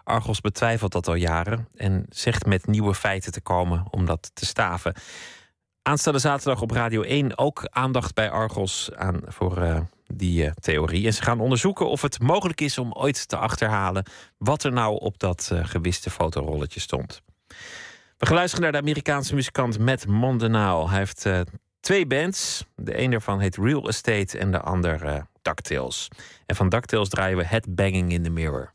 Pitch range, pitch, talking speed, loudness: 90-125 Hz, 105 Hz, 180 wpm, -24 LUFS